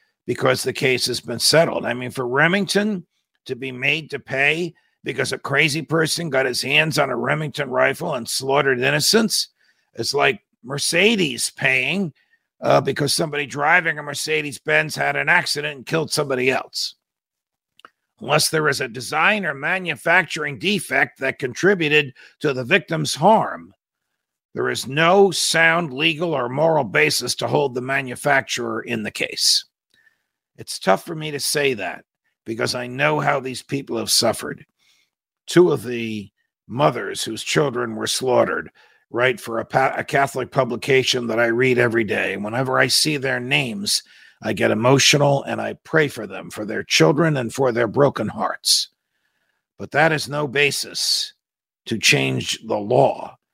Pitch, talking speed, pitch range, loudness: 145 Hz, 160 wpm, 130-160 Hz, -19 LUFS